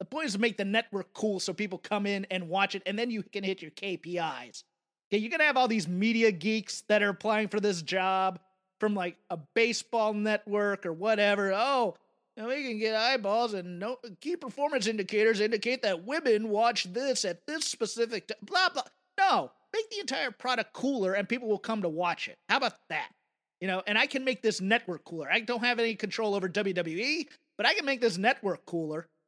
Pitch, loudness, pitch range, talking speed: 215 Hz, -29 LUFS, 190-240 Hz, 215 wpm